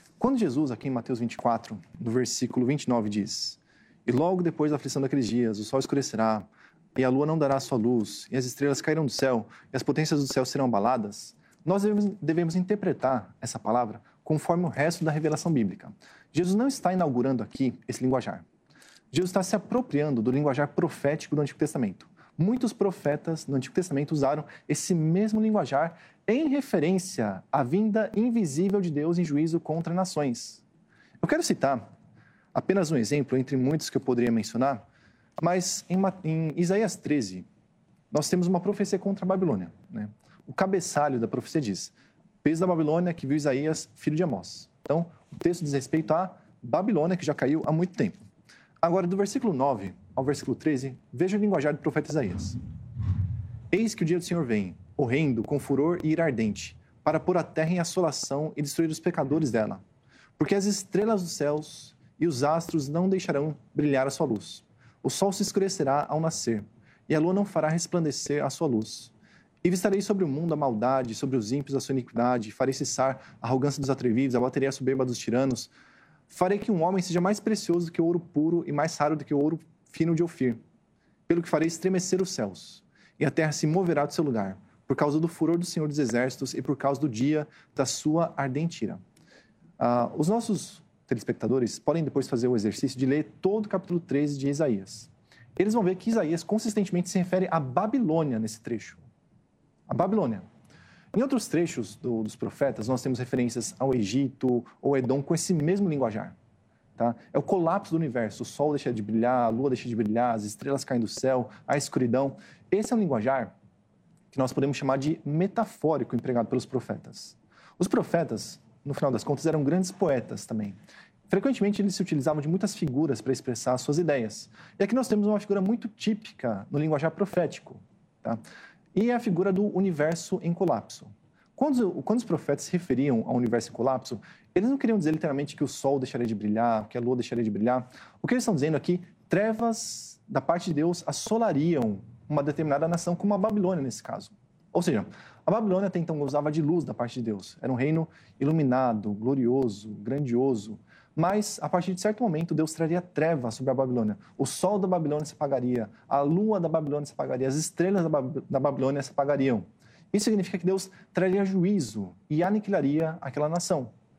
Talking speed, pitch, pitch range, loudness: 190 wpm, 150 Hz, 130-180 Hz, -28 LUFS